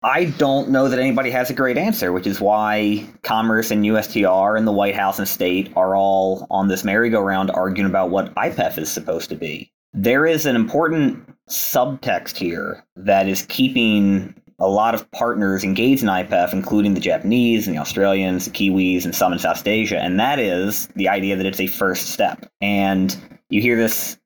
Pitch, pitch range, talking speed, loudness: 100 Hz, 95-115 Hz, 190 wpm, -19 LUFS